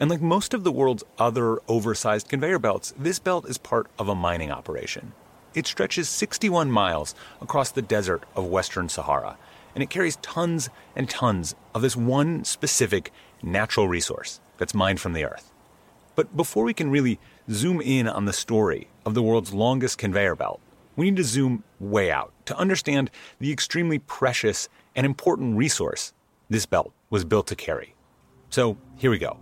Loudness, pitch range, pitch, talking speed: -25 LUFS, 105-150 Hz, 125 Hz, 175 wpm